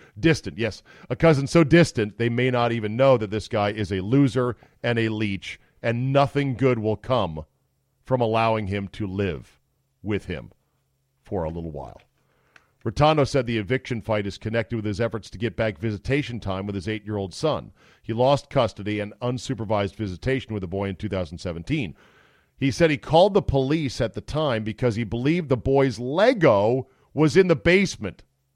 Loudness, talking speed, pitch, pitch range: -23 LUFS, 185 wpm, 115 Hz, 105-135 Hz